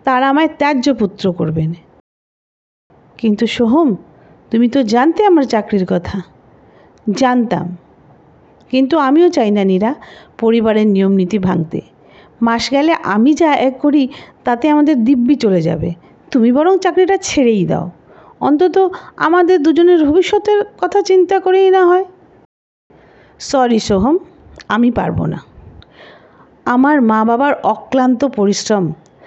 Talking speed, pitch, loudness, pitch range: 115 wpm, 255 Hz, -13 LUFS, 200-320 Hz